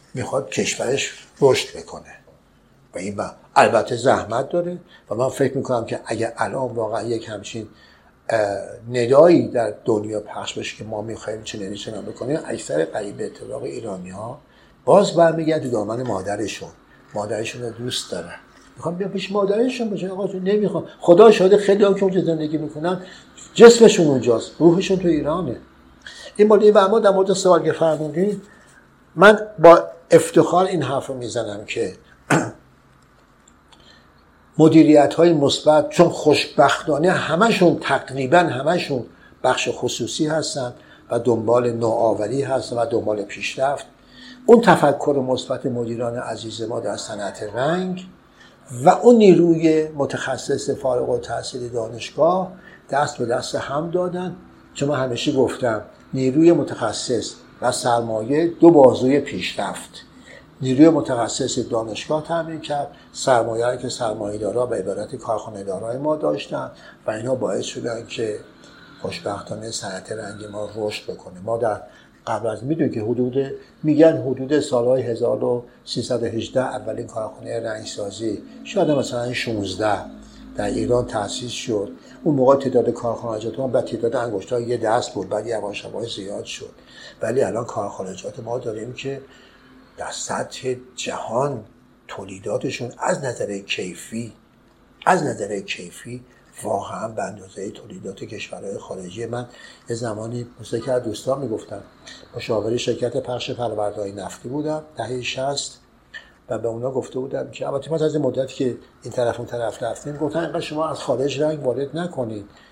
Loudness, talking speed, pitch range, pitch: -20 LUFS, 140 wpm, 115-165 Hz, 130 Hz